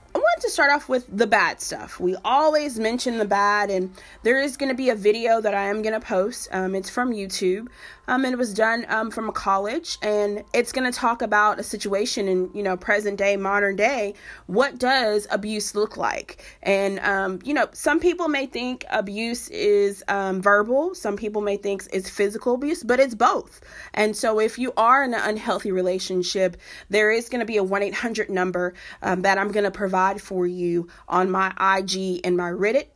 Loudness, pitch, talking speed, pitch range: -22 LUFS, 210 Hz, 210 wpm, 195-245 Hz